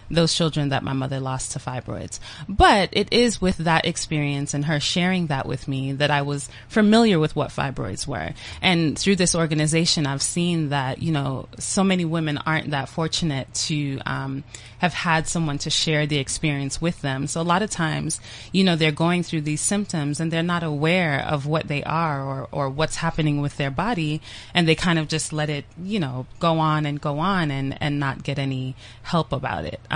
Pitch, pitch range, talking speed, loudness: 155 Hz, 140-165 Hz, 210 wpm, -22 LUFS